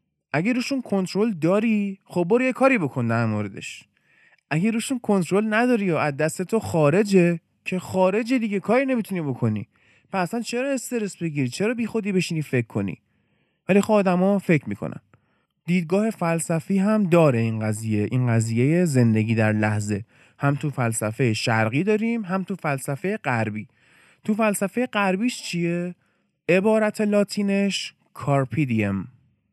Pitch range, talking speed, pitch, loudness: 125-210 Hz, 140 wpm, 175 Hz, -23 LUFS